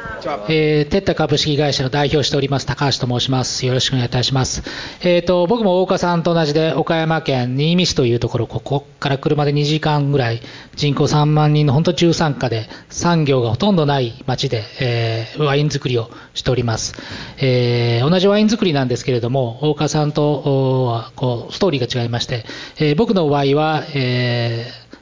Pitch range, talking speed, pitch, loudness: 125-155 Hz, 360 characters per minute, 140 Hz, -17 LUFS